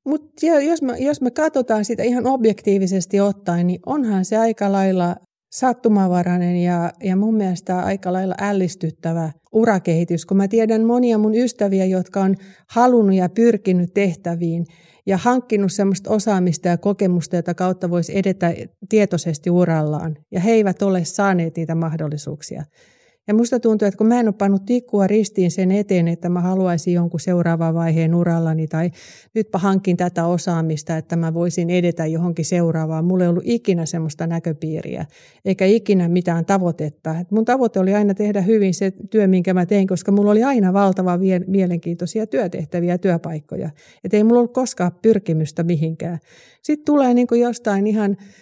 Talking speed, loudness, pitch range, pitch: 155 wpm, -19 LUFS, 170-210 Hz, 185 Hz